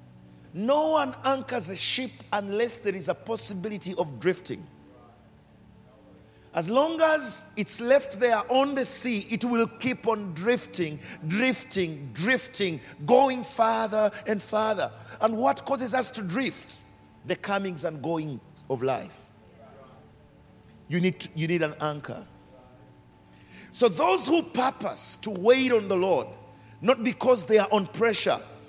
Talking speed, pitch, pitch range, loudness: 135 wpm, 210 Hz, 170-250 Hz, -26 LUFS